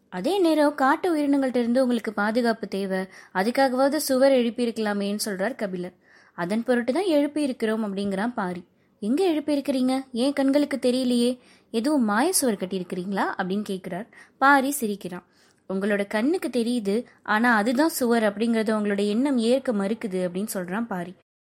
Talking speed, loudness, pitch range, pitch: 125 wpm, -24 LUFS, 200-270 Hz, 235 Hz